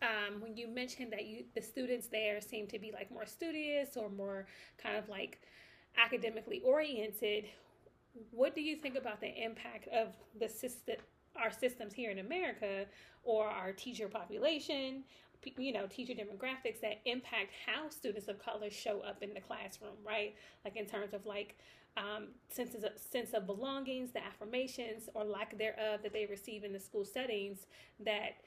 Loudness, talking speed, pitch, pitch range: -40 LUFS, 170 wpm, 220 Hz, 210-250 Hz